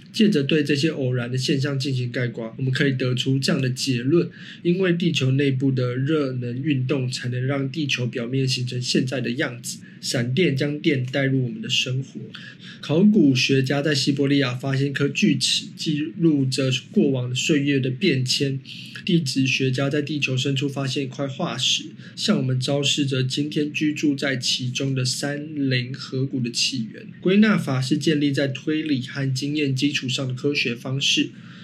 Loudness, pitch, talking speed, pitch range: -22 LUFS, 140 Hz, 270 characters per minute, 130-150 Hz